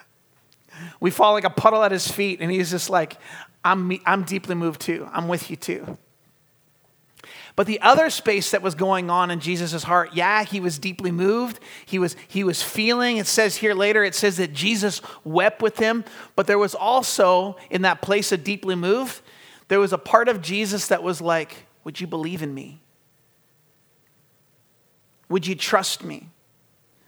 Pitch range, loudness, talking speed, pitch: 165-205 Hz, -21 LUFS, 180 wpm, 185 Hz